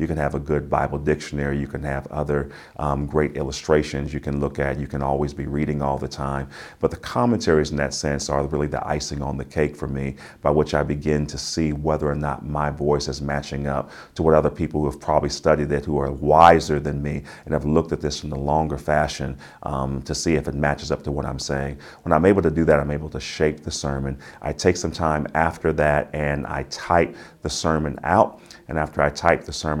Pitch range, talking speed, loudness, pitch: 70-75 Hz, 240 wpm, -23 LUFS, 75 Hz